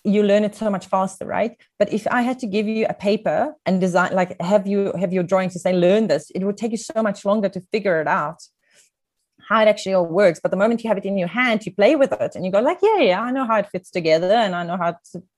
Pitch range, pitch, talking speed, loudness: 185-220 Hz, 205 Hz, 290 wpm, -20 LUFS